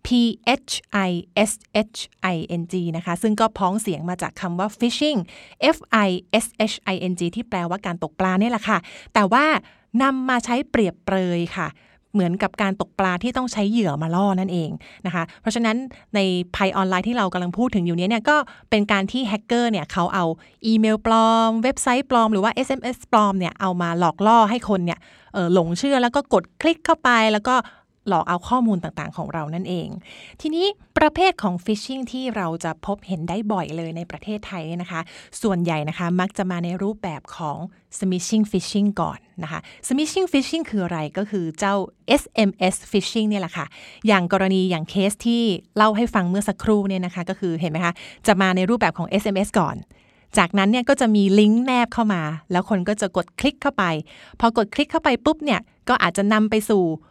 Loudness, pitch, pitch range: -21 LUFS, 205 Hz, 180-230 Hz